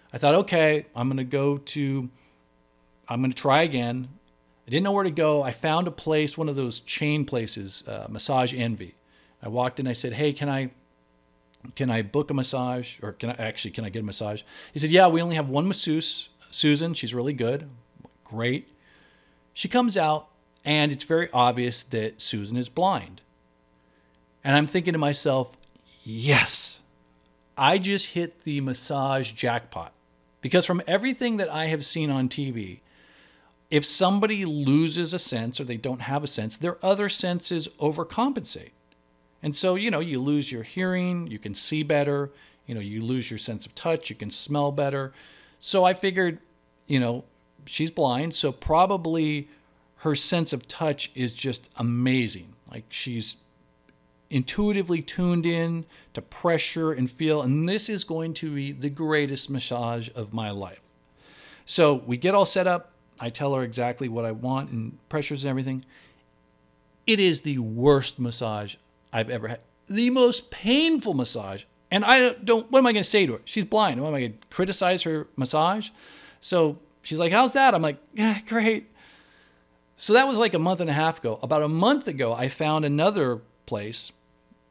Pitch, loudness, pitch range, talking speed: 140 Hz, -24 LUFS, 115-165 Hz, 175 wpm